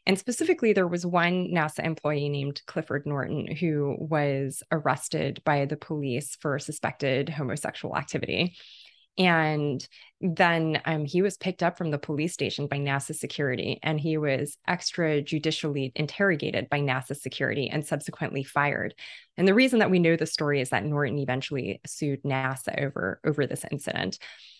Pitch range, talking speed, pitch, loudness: 140-165 Hz, 155 wpm, 150 Hz, -27 LUFS